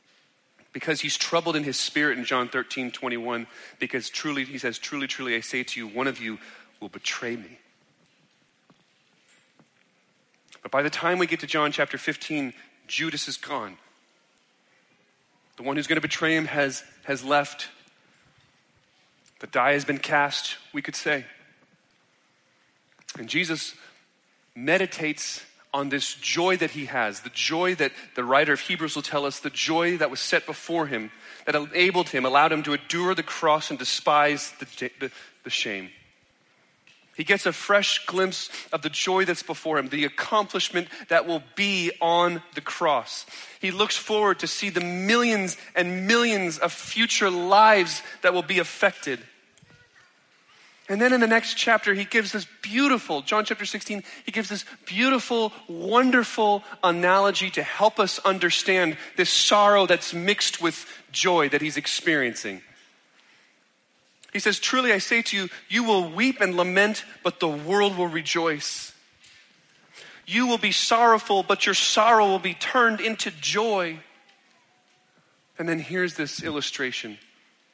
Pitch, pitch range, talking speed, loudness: 175 Hz, 150-205 Hz, 155 wpm, -24 LUFS